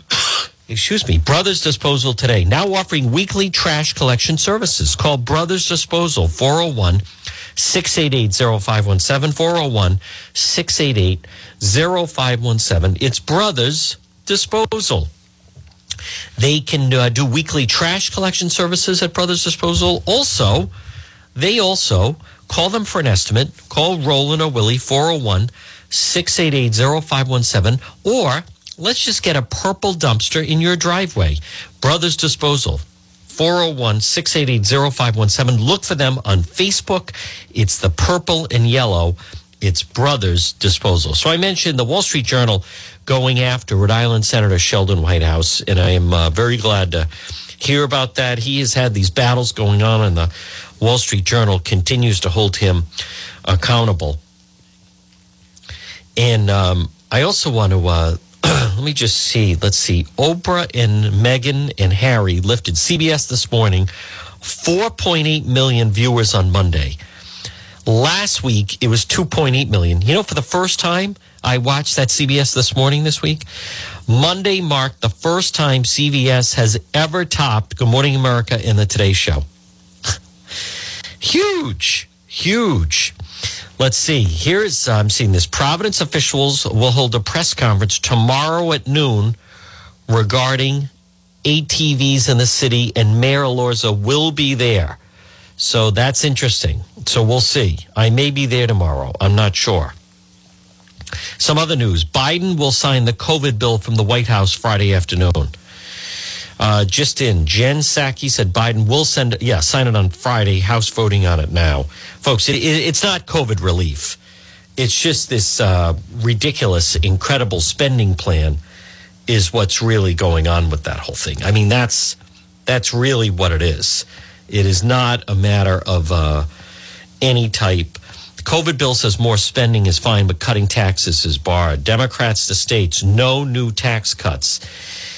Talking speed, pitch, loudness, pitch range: 140 wpm, 115 Hz, -15 LUFS, 95-140 Hz